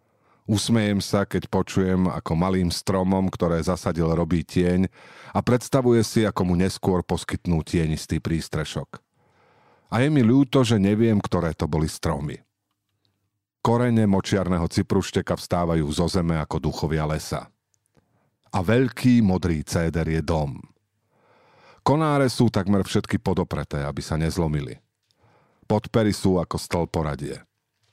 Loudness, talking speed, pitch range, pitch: -23 LUFS, 125 wpm, 85-105 Hz, 95 Hz